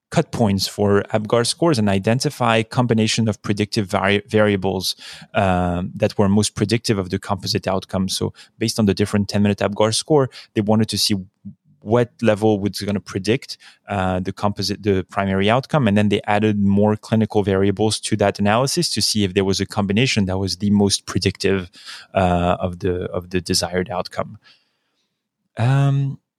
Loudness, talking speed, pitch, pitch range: -19 LUFS, 170 wpm, 105 Hz, 95-110 Hz